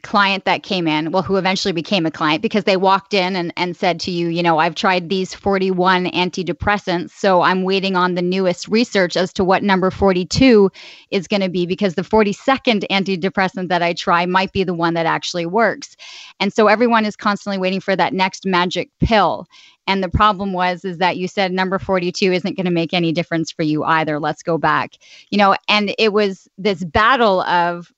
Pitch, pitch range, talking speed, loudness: 190 Hz, 175-200 Hz, 210 wpm, -17 LUFS